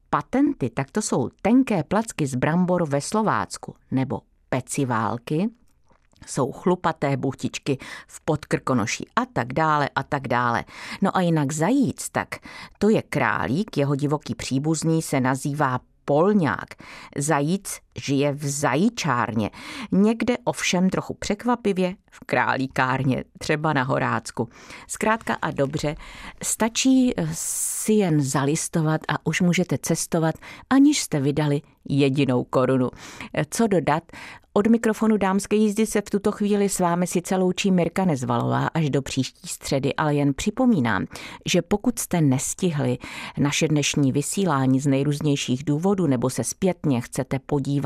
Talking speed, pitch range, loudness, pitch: 130 wpm, 140-200 Hz, -23 LUFS, 155 Hz